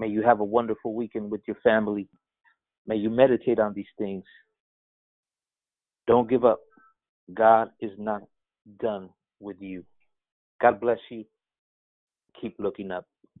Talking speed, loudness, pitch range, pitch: 135 wpm, -25 LUFS, 95-115 Hz, 110 Hz